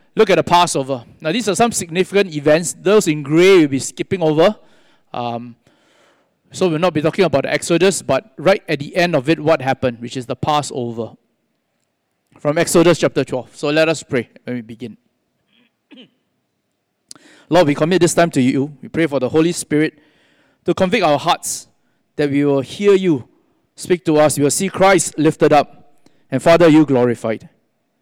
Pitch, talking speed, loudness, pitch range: 155 Hz, 180 wpm, -16 LUFS, 135-175 Hz